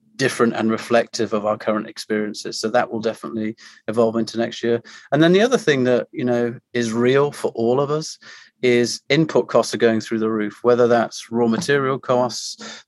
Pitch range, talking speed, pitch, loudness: 110-125 Hz, 195 wpm, 115 Hz, -20 LUFS